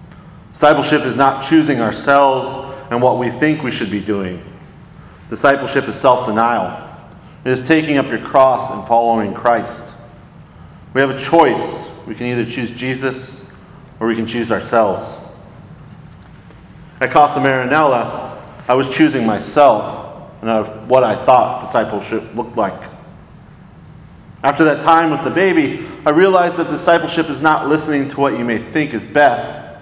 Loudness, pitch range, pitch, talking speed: -15 LUFS, 120-155 Hz, 135 Hz, 150 wpm